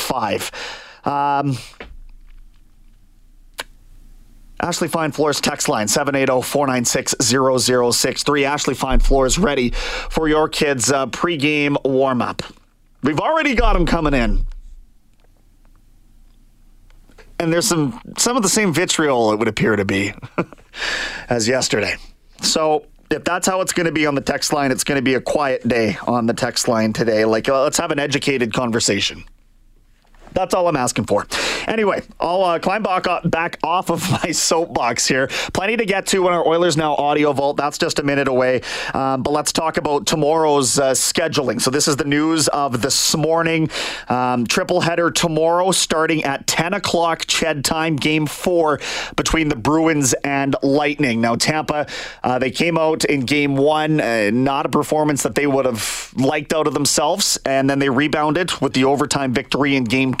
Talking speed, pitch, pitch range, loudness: 165 wpm, 145 Hz, 125-160 Hz, -18 LUFS